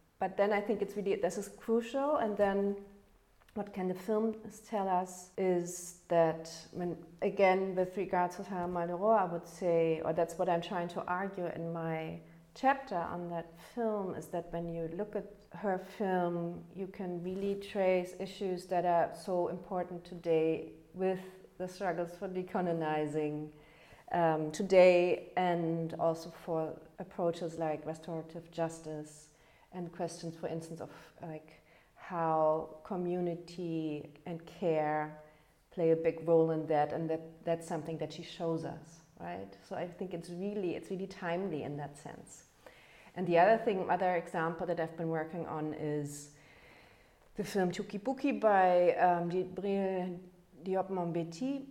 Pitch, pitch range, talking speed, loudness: 175 Hz, 165-190 Hz, 150 wpm, -34 LUFS